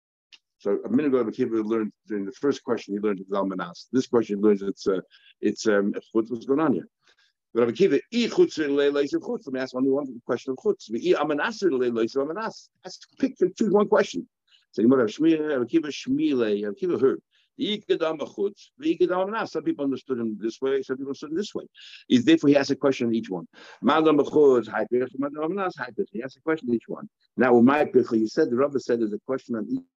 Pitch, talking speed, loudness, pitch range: 135 Hz, 225 wpm, -25 LUFS, 115-190 Hz